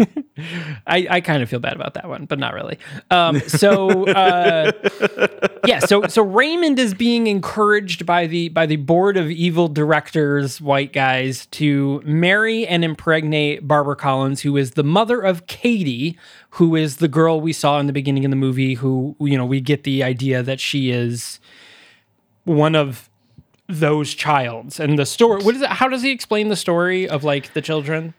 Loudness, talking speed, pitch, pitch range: -18 LUFS, 185 wpm, 155 Hz, 140-185 Hz